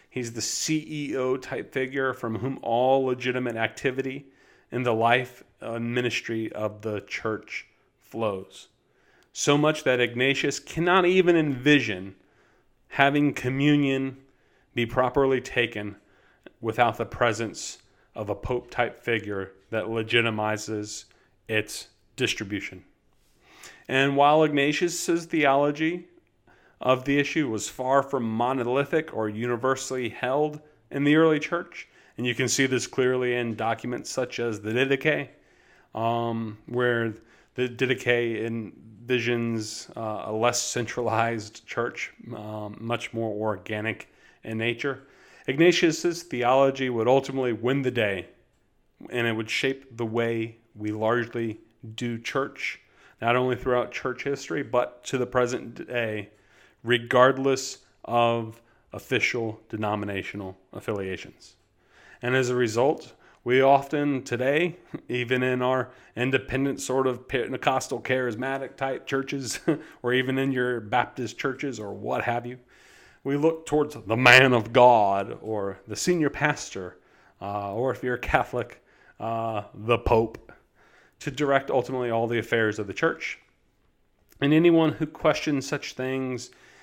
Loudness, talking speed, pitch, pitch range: -25 LUFS, 125 wpm, 125 Hz, 115-135 Hz